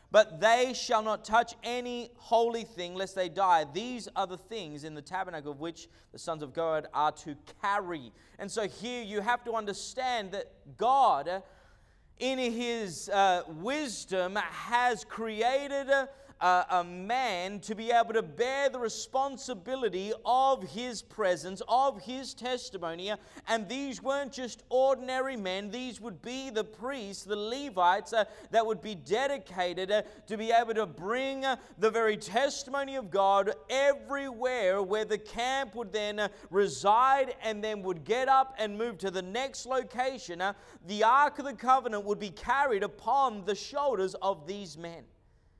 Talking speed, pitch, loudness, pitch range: 160 wpm, 220 Hz, -31 LUFS, 195-255 Hz